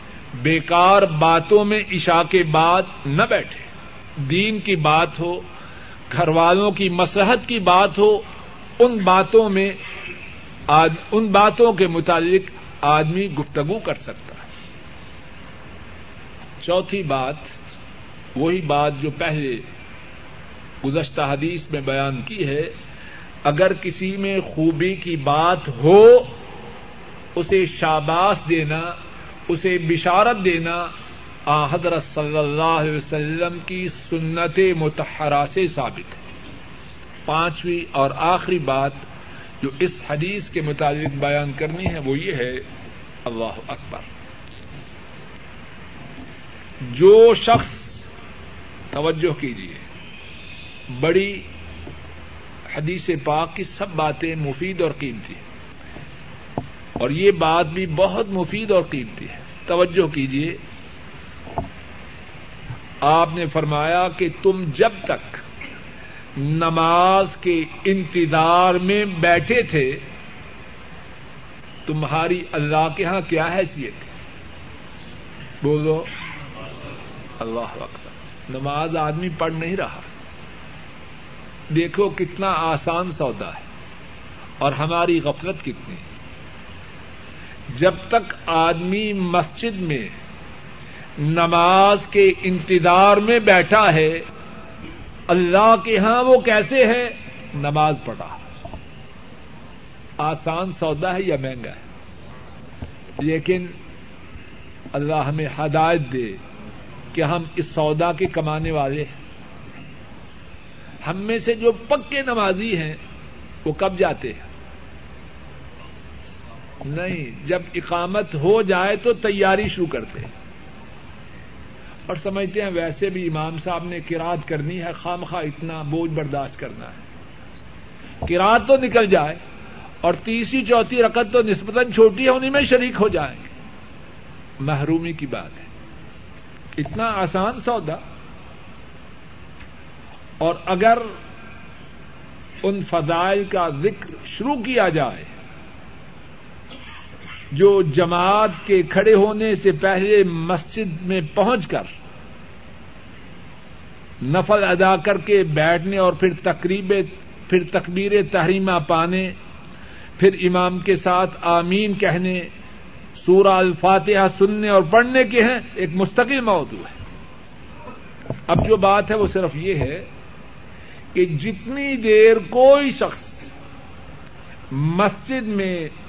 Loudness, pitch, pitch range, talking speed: -19 LUFS, 170 Hz, 145-195 Hz, 105 wpm